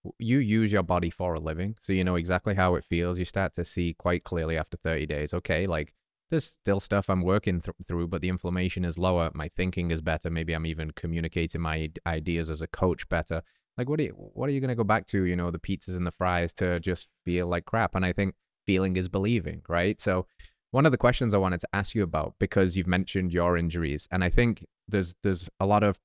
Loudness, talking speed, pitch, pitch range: -28 LUFS, 245 wpm, 90 Hz, 85-100 Hz